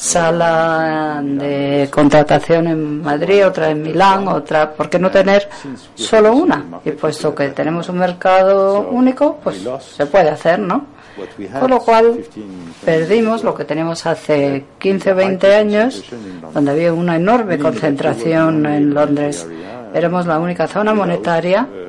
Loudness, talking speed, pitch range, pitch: -14 LUFS, 135 wpm, 150-195 Hz, 165 Hz